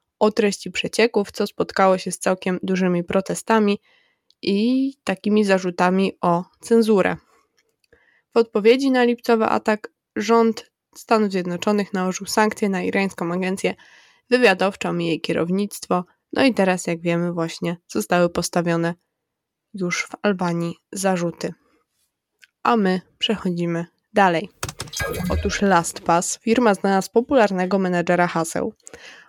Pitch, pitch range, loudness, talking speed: 190 Hz, 175-220 Hz, -21 LUFS, 115 wpm